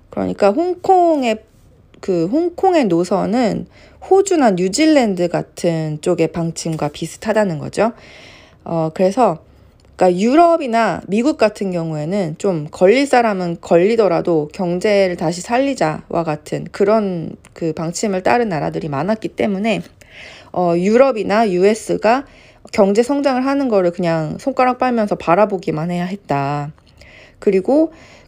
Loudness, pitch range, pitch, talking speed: -17 LUFS, 170-240 Hz, 200 Hz, 280 characters per minute